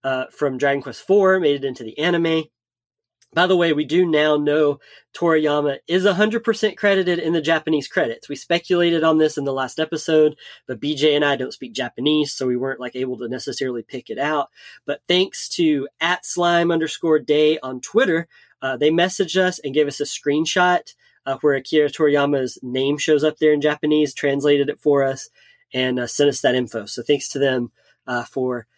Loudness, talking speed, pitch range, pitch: -20 LUFS, 195 wpm, 135-165 Hz, 150 Hz